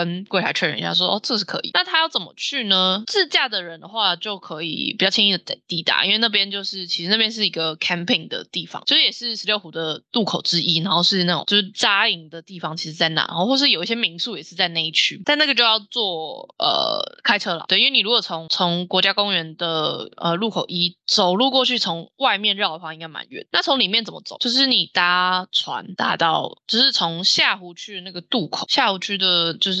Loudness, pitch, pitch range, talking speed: -19 LUFS, 190 Hz, 170-225 Hz, 350 characters per minute